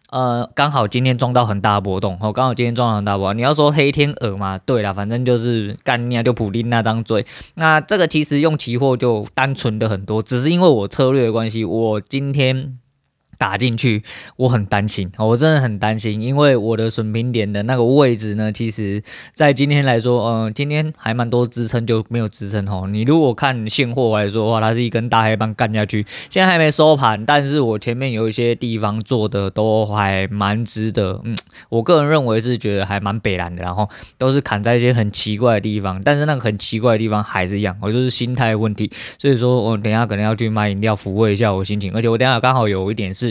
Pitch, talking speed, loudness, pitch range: 115 Hz, 340 characters per minute, -17 LUFS, 105-130 Hz